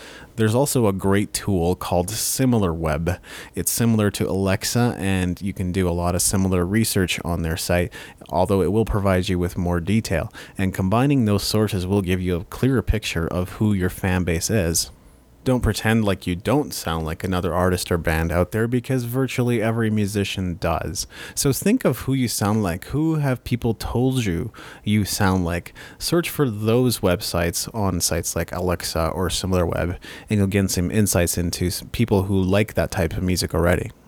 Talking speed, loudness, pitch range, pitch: 185 wpm, -22 LUFS, 90-110 Hz, 95 Hz